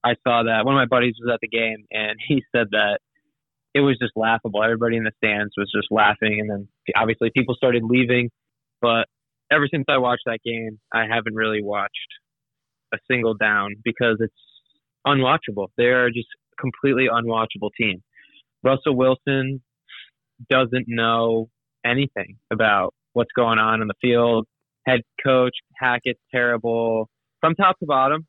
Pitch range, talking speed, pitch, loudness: 110-130 Hz, 160 wpm, 120 Hz, -21 LUFS